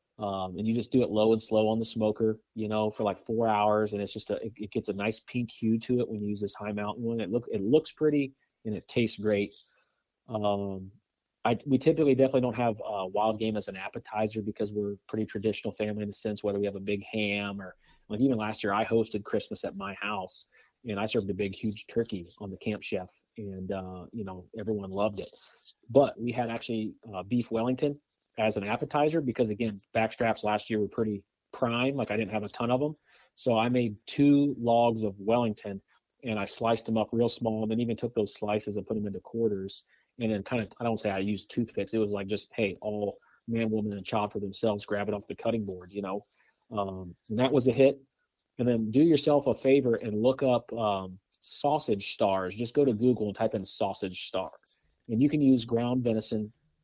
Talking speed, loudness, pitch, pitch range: 230 wpm, -30 LUFS, 110 Hz, 105-120 Hz